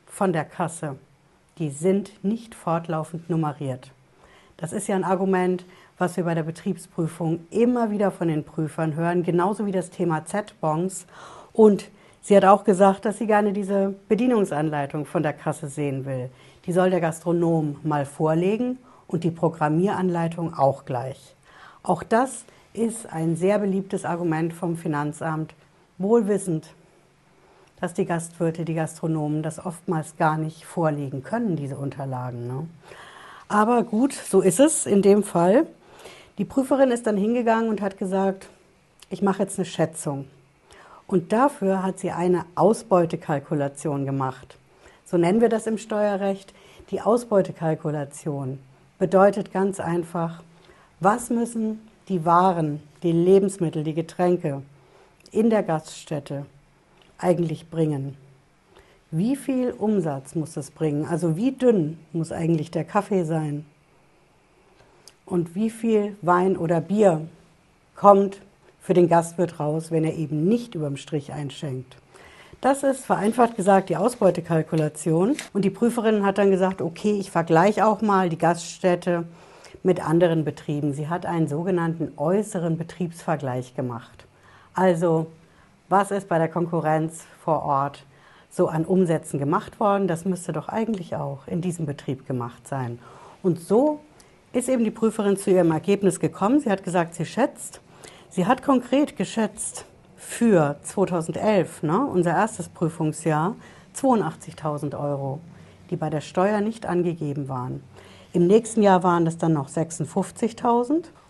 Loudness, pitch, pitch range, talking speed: -23 LUFS, 175 Hz, 155-195 Hz, 140 wpm